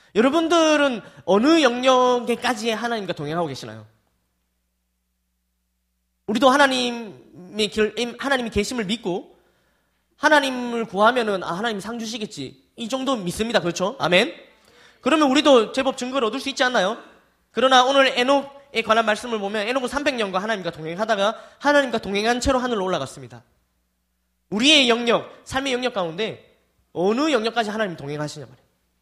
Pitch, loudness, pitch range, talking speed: 225 Hz, -21 LUFS, 170-255 Hz, 340 characters per minute